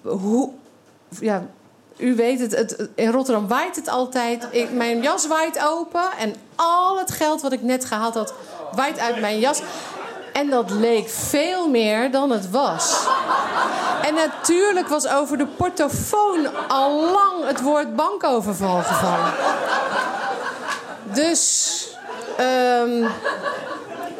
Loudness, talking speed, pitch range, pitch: -21 LUFS, 125 wpm, 235-315 Hz, 275 Hz